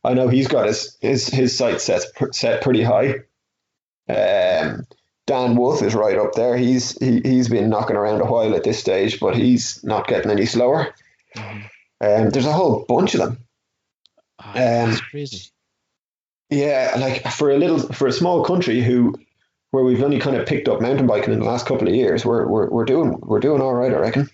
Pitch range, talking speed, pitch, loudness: 115-140 Hz, 195 wpm, 125 Hz, -18 LUFS